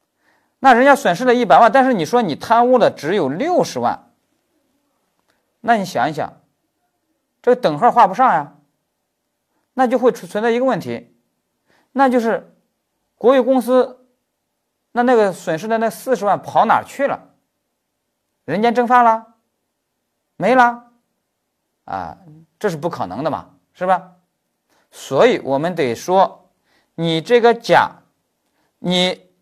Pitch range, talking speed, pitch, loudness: 185-255 Hz, 190 characters per minute, 240 Hz, -16 LUFS